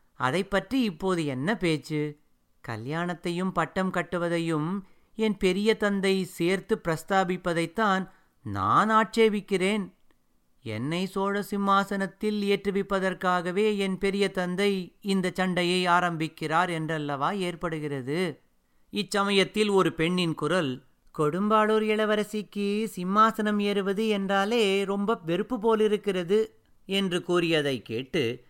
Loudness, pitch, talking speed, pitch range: -27 LUFS, 190 Hz, 90 wpm, 165-205 Hz